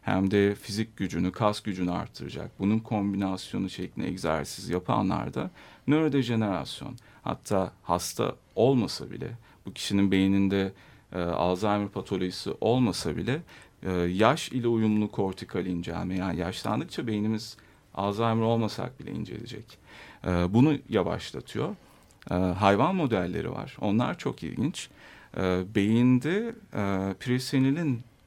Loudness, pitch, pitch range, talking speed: -28 LUFS, 100 Hz, 95-115 Hz, 110 wpm